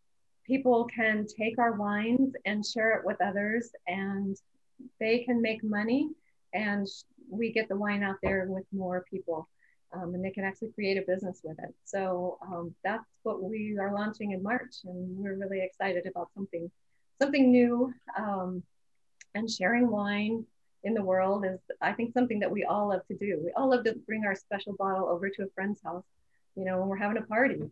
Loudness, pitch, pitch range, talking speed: -31 LUFS, 205 Hz, 190-225 Hz, 195 wpm